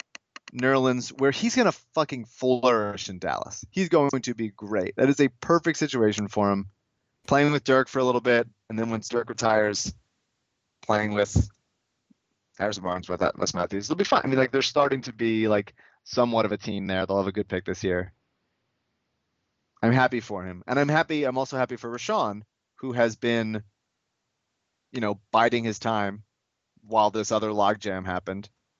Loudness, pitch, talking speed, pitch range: -25 LUFS, 115 Hz, 185 wpm, 105-130 Hz